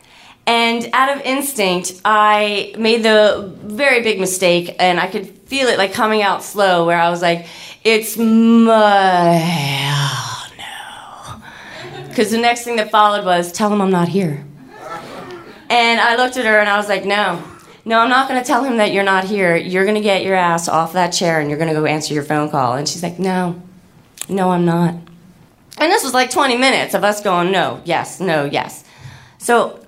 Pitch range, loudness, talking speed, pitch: 175-225 Hz, -15 LUFS, 200 wpm, 195 Hz